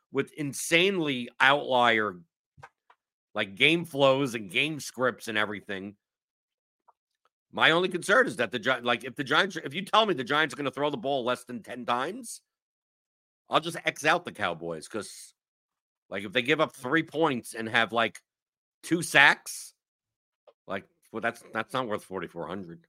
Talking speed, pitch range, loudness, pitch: 165 wpm, 115-155 Hz, -26 LUFS, 130 Hz